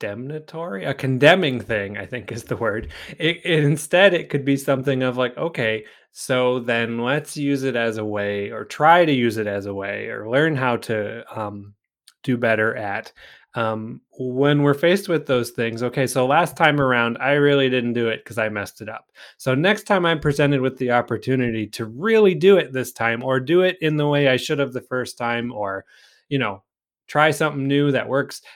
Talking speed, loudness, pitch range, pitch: 210 wpm, -20 LUFS, 115-150 Hz, 130 Hz